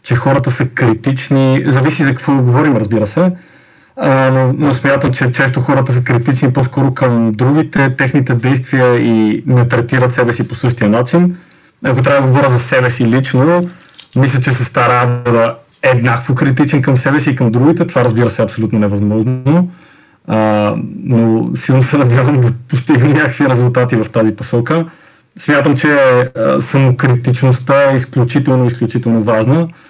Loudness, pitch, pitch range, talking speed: -12 LUFS, 130 Hz, 120-140 Hz, 160 wpm